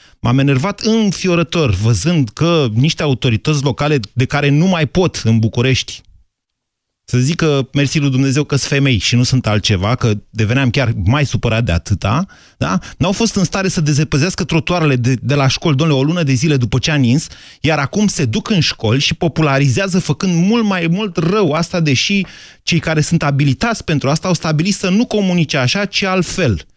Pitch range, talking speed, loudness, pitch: 125-175 Hz, 190 wpm, -15 LUFS, 145 Hz